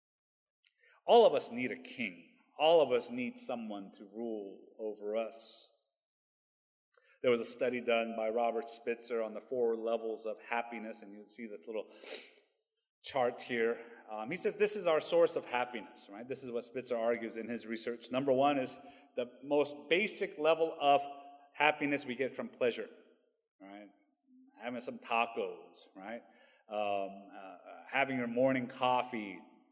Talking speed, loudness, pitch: 160 wpm, -34 LUFS, 125 Hz